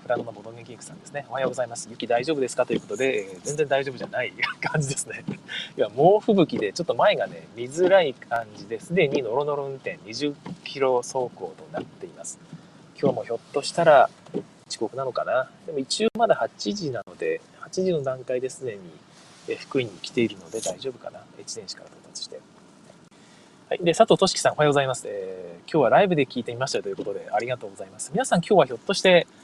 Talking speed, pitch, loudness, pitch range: 435 characters per minute, 145 Hz, -24 LUFS, 125-185 Hz